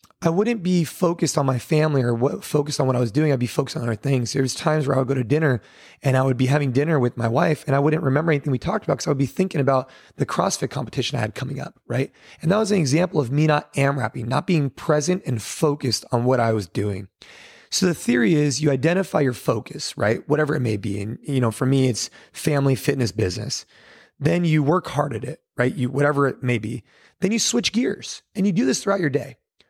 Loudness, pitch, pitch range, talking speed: -22 LUFS, 140 Hz, 125-155 Hz, 255 wpm